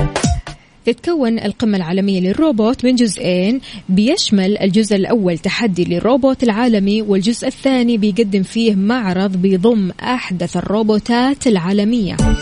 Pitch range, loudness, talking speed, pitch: 195-240 Hz, -15 LUFS, 100 wpm, 215 Hz